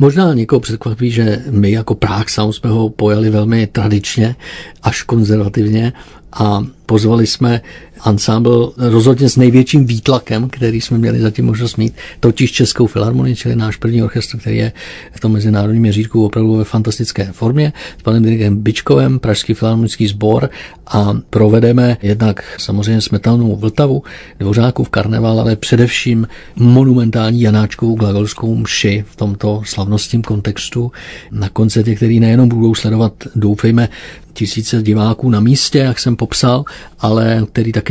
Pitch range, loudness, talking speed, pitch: 105-120 Hz, -13 LUFS, 140 wpm, 110 Hz